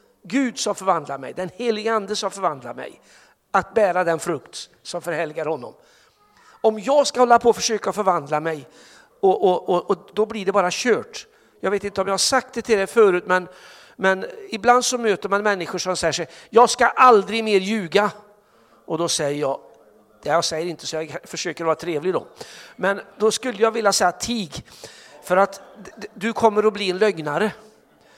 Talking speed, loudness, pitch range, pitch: 185 wpm, -21 LUFS, 175-225 Hz, 200 Hz